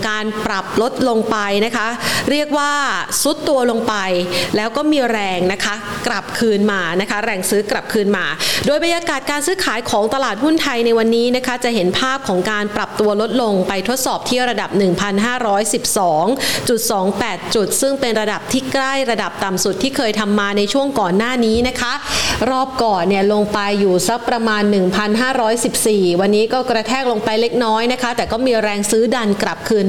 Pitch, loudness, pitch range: 225 Hz, -16 LUFS, 205-250 Hz